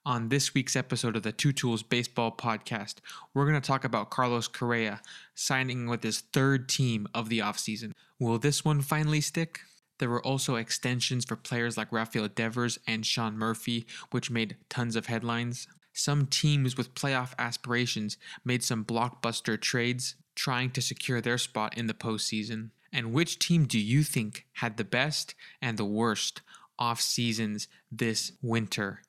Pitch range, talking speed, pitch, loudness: 115-135 Hz, 165 wpm, 120 Hz, -30 LUFS